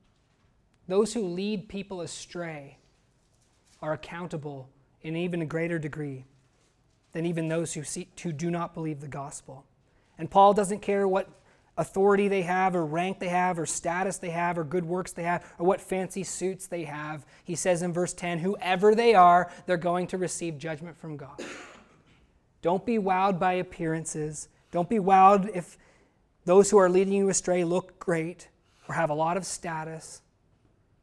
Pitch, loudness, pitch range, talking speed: 170 Hz, -27 LUFS, 155-185 Hz, 170 wpm